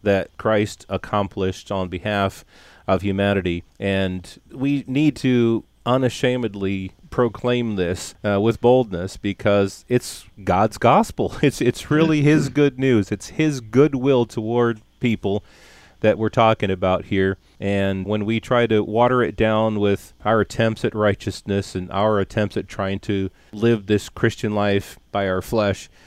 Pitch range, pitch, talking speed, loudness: 95-120 Hz, 105 Hz, 145 wpm, -21 LUFS